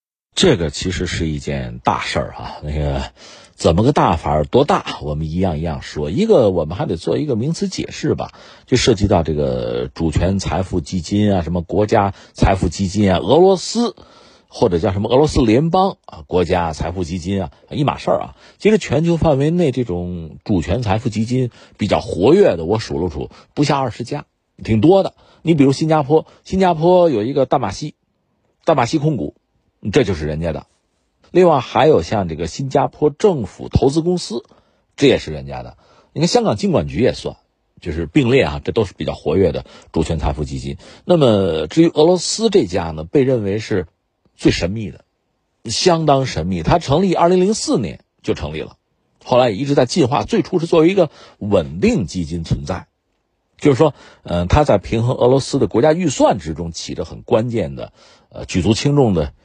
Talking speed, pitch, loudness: 285 characters per minute, 105 Hz, -17 LUFS